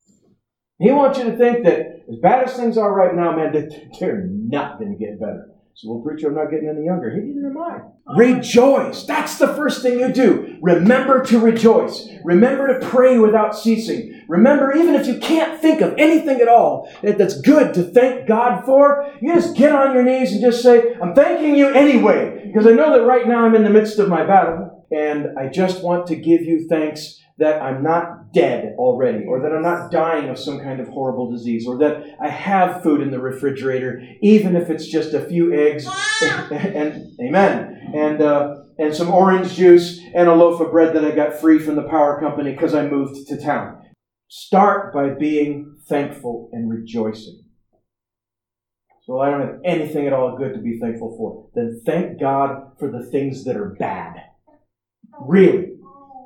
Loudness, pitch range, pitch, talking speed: -16 LUFS, 150-240 Hz, 175 Hz, 200 wpm